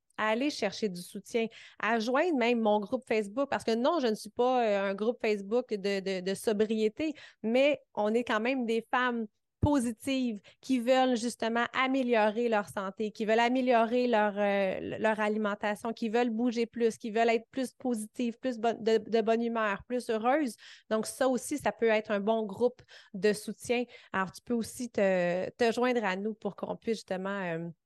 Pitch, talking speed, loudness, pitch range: 230 Hz, 190 wpm, -30 LUFS, 210-245 Hz